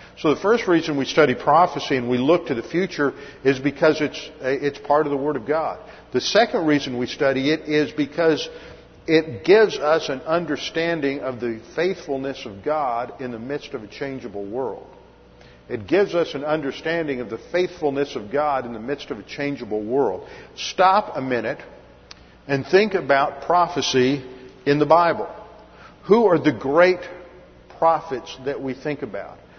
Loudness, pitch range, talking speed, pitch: -21 LUFS, 135-165 Hz, 170 wpm, 145 Hz